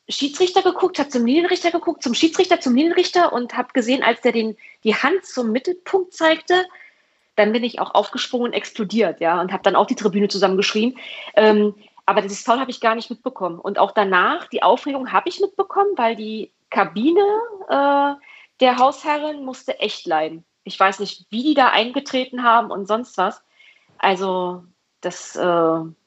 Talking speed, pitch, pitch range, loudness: 175 wpm, 240 Hz, 200-305 Hz, -19 LUFS